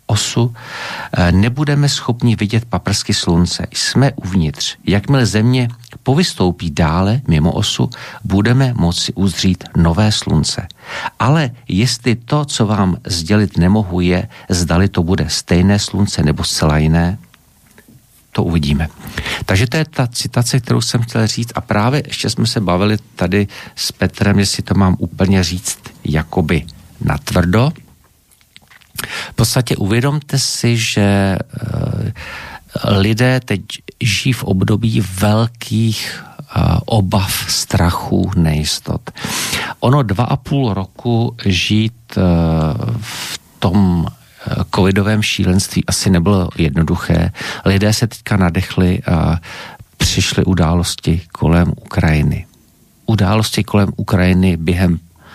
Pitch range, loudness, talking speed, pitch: 90-120 Hz, -15 LUFS, 110 wpm, 100 Hz